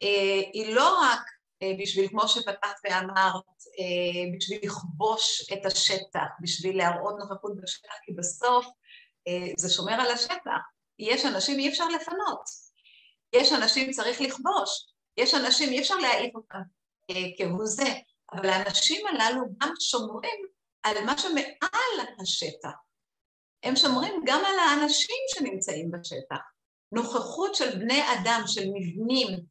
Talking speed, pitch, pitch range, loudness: 130 wpm, 225 Hz, 195-280 Hz, -26 LUFS